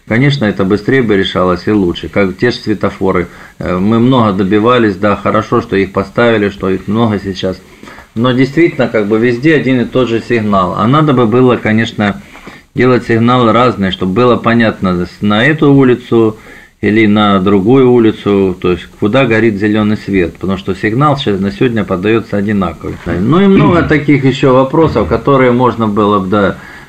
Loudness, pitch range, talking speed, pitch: -10 LUFS, 100-125 Hz, 170 wpm, 110 Hz